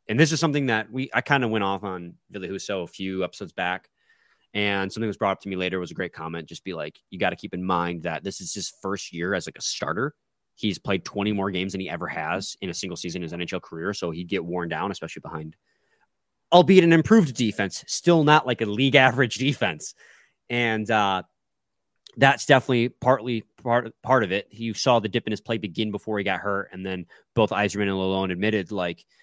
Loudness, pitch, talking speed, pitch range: -24 LUFS, 105 Hz, 230 wpm, 95-120 Hz